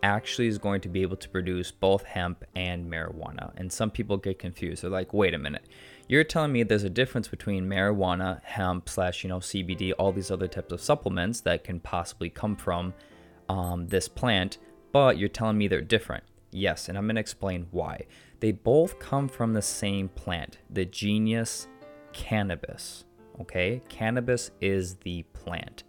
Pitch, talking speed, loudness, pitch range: 95 Hz, 175 wpm, -29 LUFS, 90-110 Hz